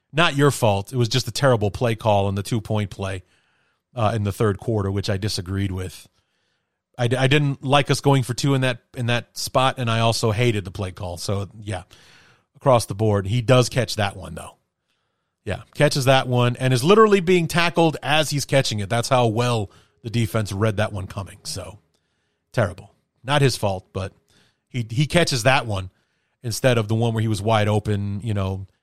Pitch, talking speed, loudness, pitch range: 115 Hz, 210 wpm, -21 LUFS, 100-130 Hz